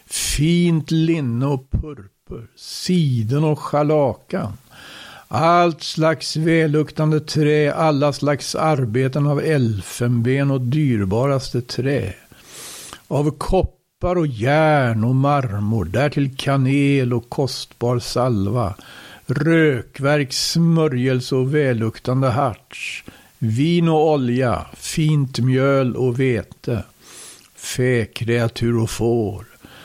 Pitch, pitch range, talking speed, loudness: 135 Hz, 120-155 Hz, 90 wpm, -19 LUFS